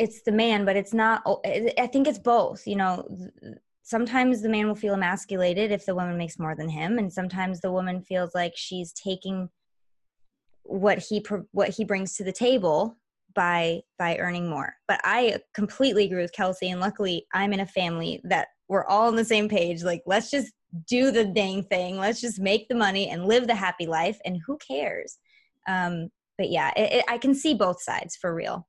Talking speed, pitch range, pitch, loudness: 200 wpm, 180-225 Hz, 195 Hz, -26 LUFS